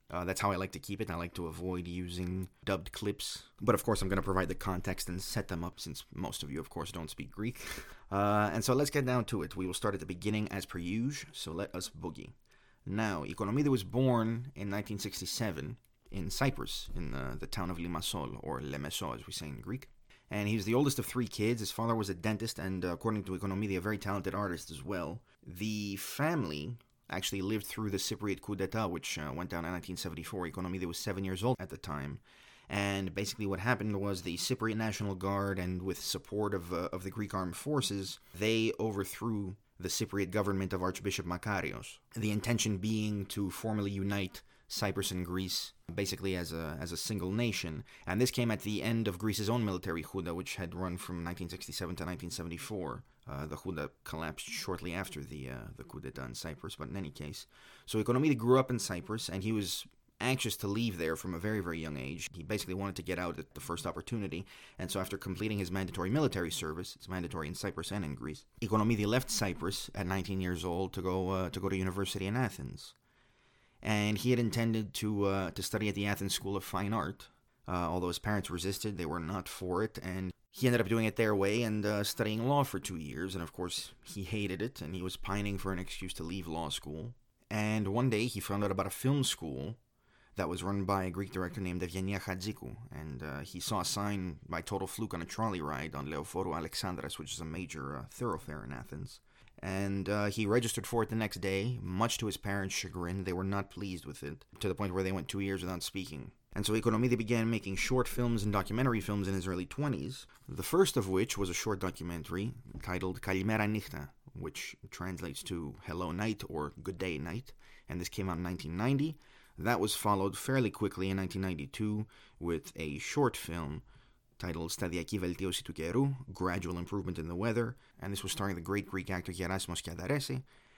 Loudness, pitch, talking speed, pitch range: -36 LUFS, 95 Hz, 215 wpm, 90-110 Hz